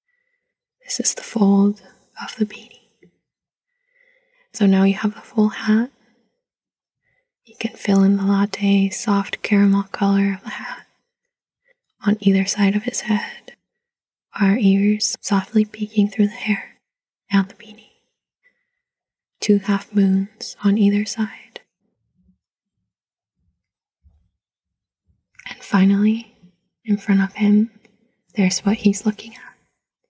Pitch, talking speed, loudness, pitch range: 210 Hz, 120 wpm, -19 LUFS, 200-235 Hz